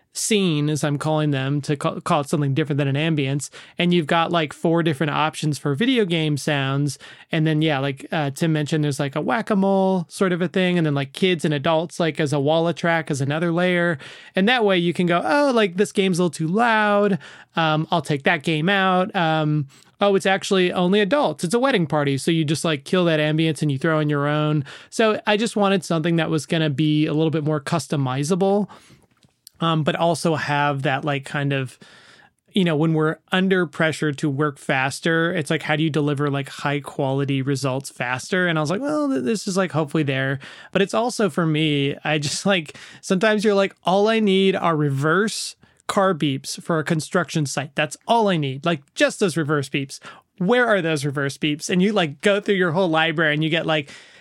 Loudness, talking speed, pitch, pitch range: -21 LUFS, 220 wpm, 160 Hz, 150-190 Hz